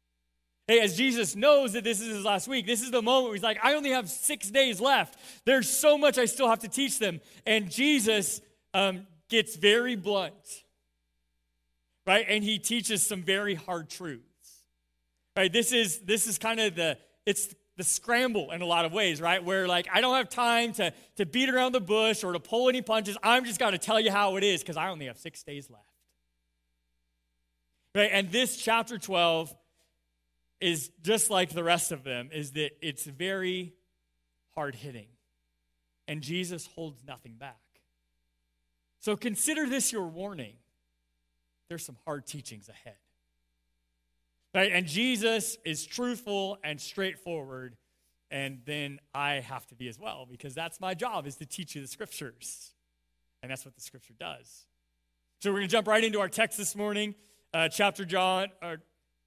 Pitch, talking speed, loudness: 175 Hz, 175 wpm, -28 LUFS